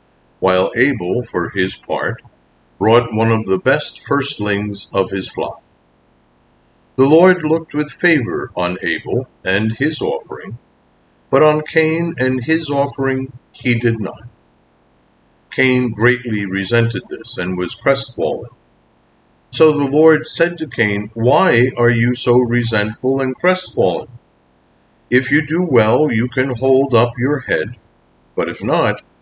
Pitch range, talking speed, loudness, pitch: 110-145 Hz, 135 wpm, -16 LUFS, 125 Hz